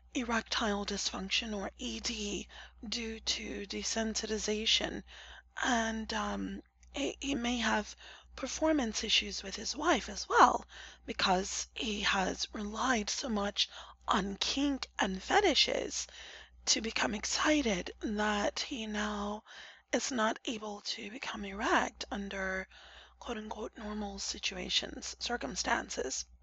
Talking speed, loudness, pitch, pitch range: 105 wpm, -33 LUFS, 220 Hz, 205-255 Hz